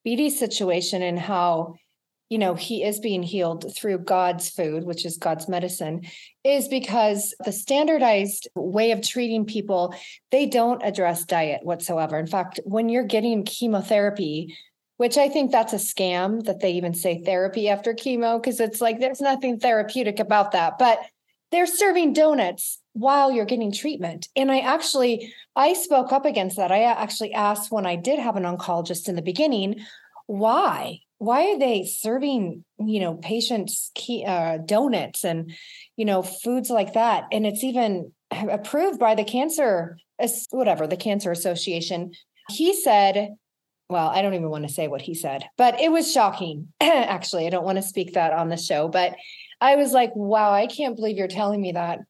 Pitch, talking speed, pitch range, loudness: 210 Hz, 175 wpm, 180-240 Hz, -23 LUFS